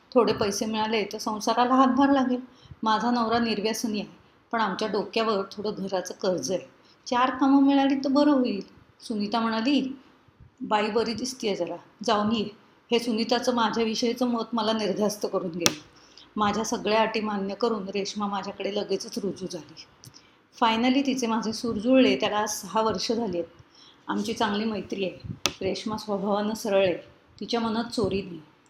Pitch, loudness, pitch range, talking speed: 220 Hz, -26 LUFS, 200-235 Hz, 155 wpm